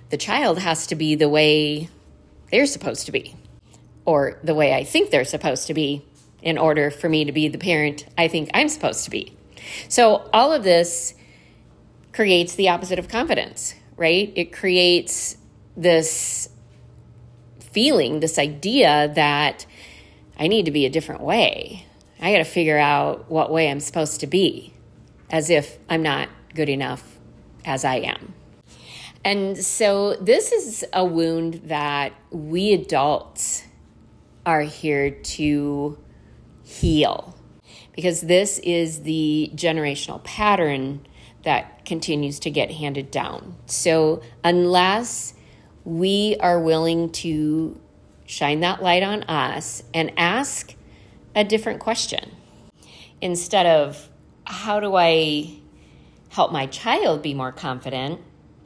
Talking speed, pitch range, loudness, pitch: 135 wpm, 150-180 Hz, -21 LUFS, 160 Hz